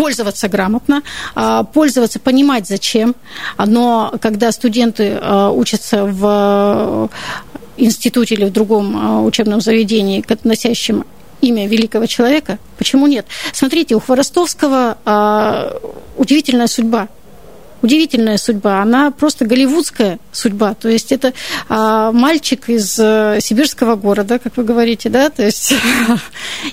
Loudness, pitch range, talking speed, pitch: -13 LUFS, 215-260 Hz, 105 wpm, 230 Hz